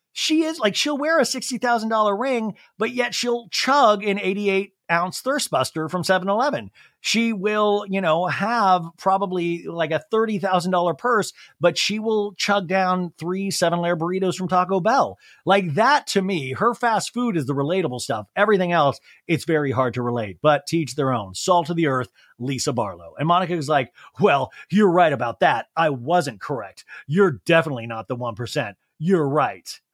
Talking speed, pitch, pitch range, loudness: 175 wpm, 185 Hz, 155-210 Hz, -21 LUFS